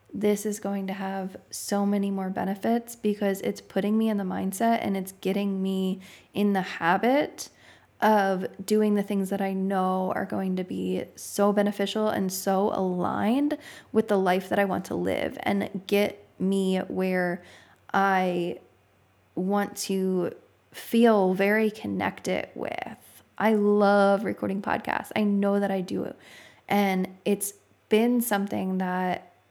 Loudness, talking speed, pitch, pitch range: -26 LUFS, 145 wpm, 195 Hz, 190-205 Hz